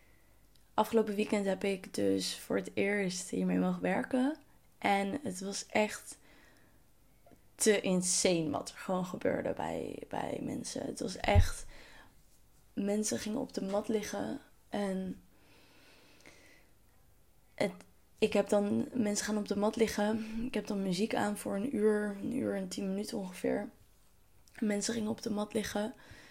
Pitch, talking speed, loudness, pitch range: 205 Hz, 145 wpm, -34 LUFS, 190-220 Hz